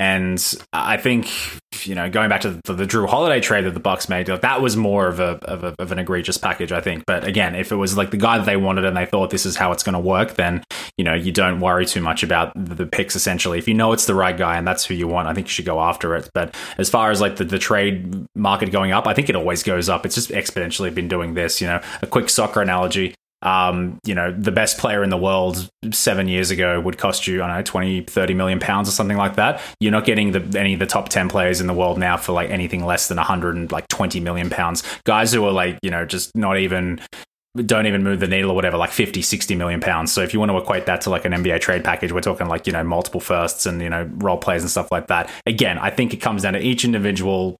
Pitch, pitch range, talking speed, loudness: 95 Hz, 90-100 Hz, 280 wpm, -19 LUFS